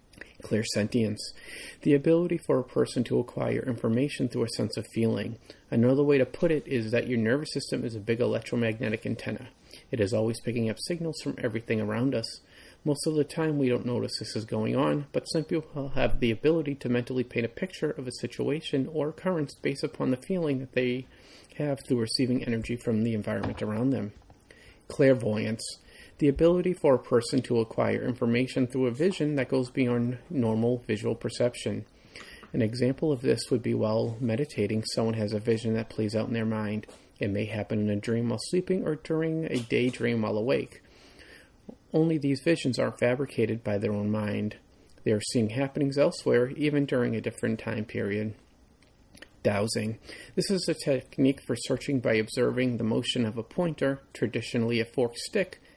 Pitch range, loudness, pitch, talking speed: 110-140 Hz, -28 LUFS, 120 Hz, 185 wpm